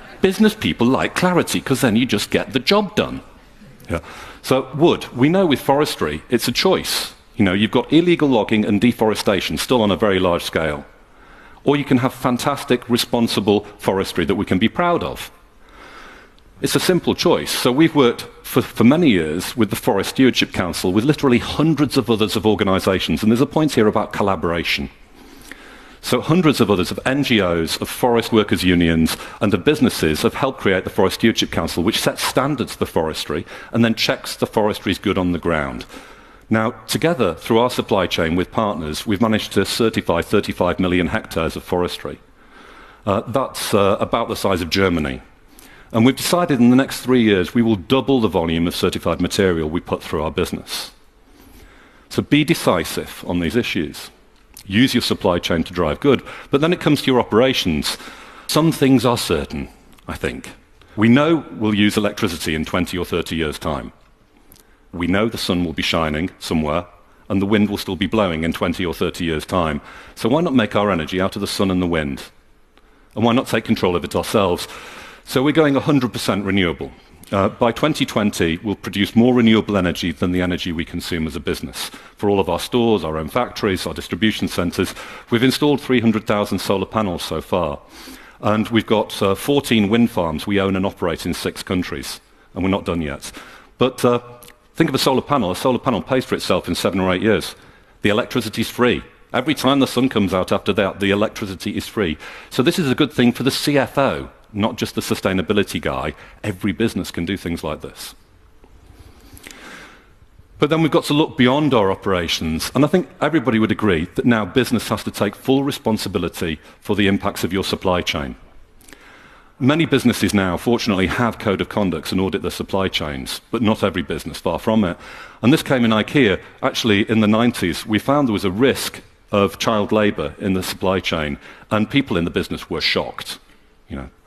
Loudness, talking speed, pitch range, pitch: -19 LUFS, 195 wpm, 90-125 Hz, 105 Hz